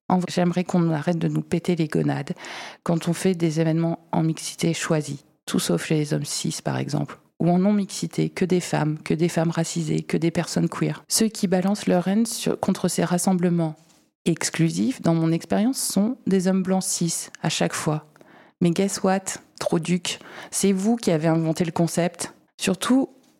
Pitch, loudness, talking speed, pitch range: 175 Hz, -23 LUFS, 185 wpm, 165-190 Hz